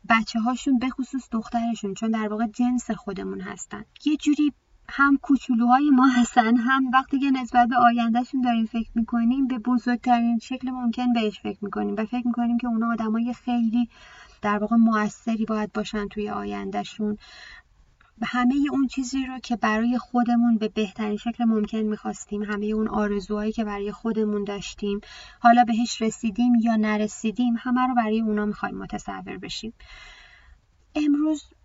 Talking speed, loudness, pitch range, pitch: 150 wpm, -24 LUFS, 215-245 Hz, 235 Hz